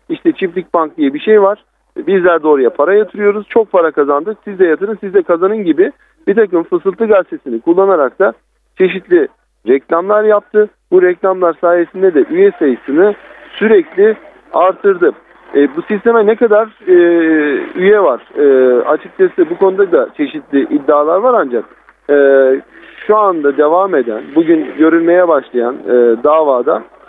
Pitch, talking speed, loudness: 205 Hz, 145 wpm, -11 LUFS